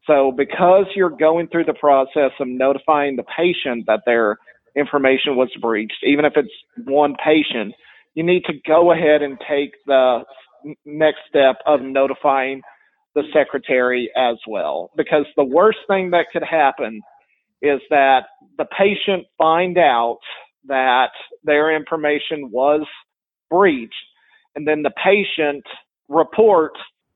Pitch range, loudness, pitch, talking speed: 135-170 Hz, -17 LUFS, 150 Hz, 135 wpm